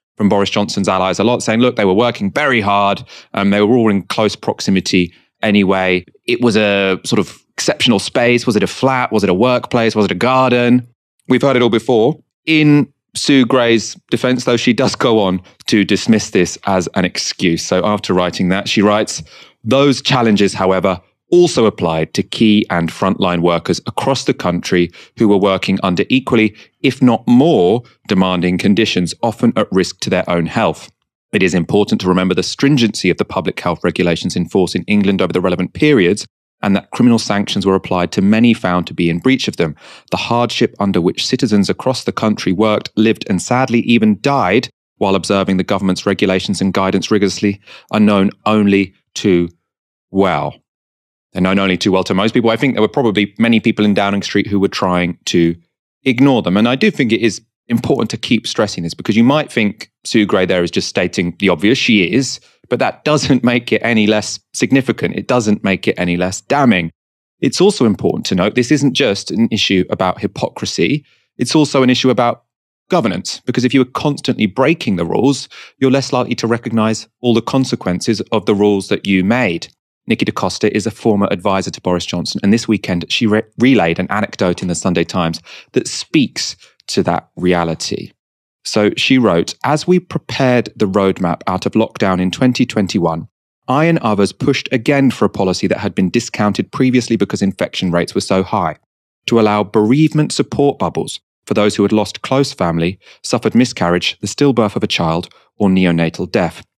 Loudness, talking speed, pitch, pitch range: -14 LUFS, 195 wpm, 105 Hz, 95-125 Hz